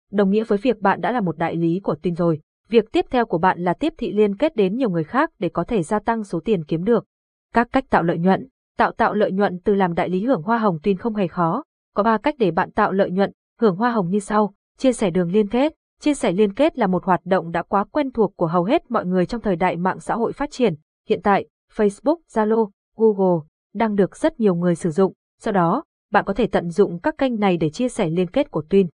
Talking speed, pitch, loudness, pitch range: 265 wpm, 205 Hz, -21 LUFS, 180-230 Hz